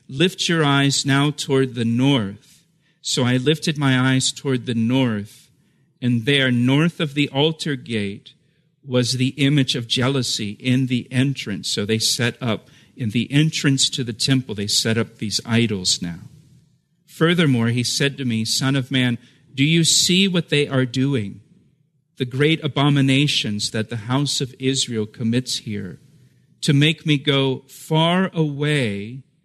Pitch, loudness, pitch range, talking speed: 135 Hz, -19 LUFS, 120-150 Hz, 155 wpm